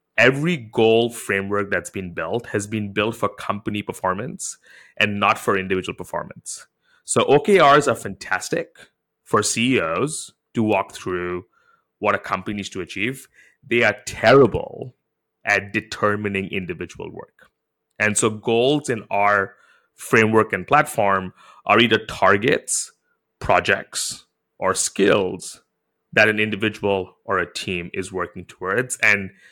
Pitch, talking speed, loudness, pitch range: 105 Hz, 130 wpm, -20 LUFS, 95-110 Hz